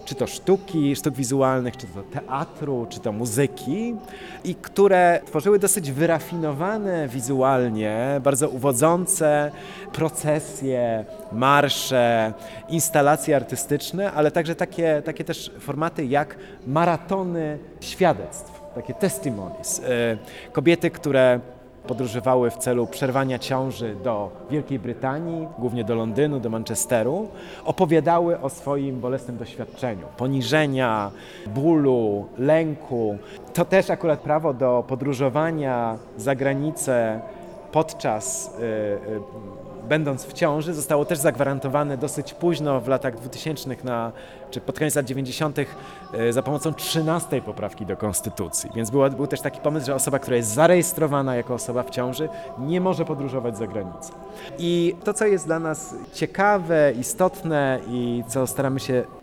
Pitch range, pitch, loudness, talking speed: 125-165 Hz, 140 Hz, -23 LUFS, 125 wpm